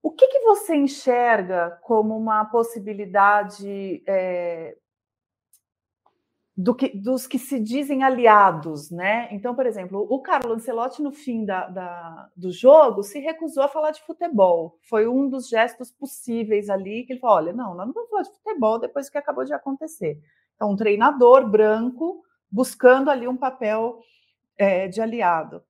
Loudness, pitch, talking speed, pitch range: -21 LUFS, 230 Hz, 160 wpm, 195-270 Hz